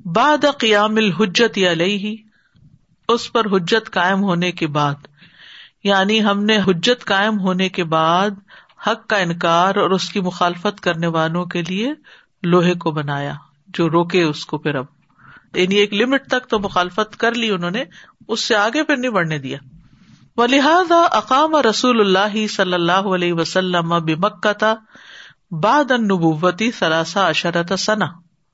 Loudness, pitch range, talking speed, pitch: -17 LUFS, 170-220 Hz, 145 wpm, 195 Hz